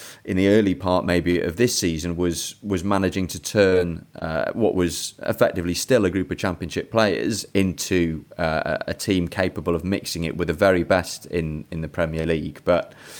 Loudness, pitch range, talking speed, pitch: -23 LUFS, 85-95 Hz, 185 wpm, 90 Hz